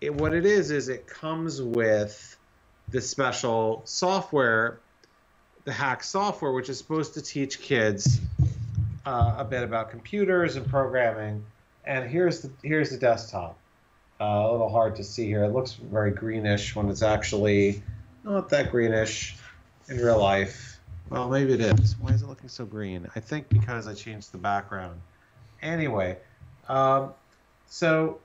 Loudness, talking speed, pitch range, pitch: -26 LUFS, 155 wpm, 105-135 Hz, 115 Hz